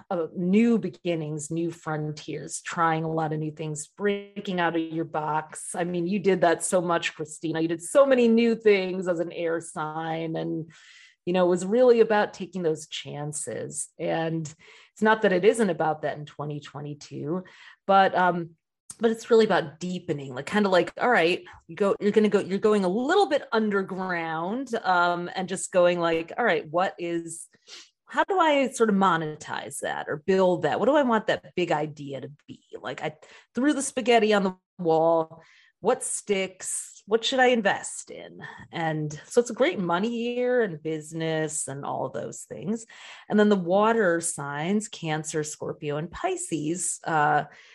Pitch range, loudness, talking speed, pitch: 160-210 Hz, -25 LUFS, 185 wpm, 175 Hz